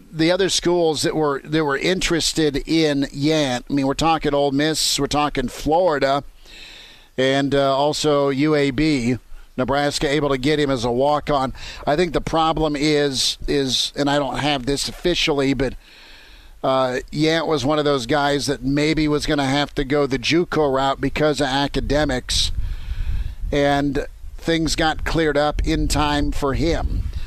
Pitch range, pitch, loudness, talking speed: 135-155 Hz, 145 Hz, -20 LUFS, 165 wpm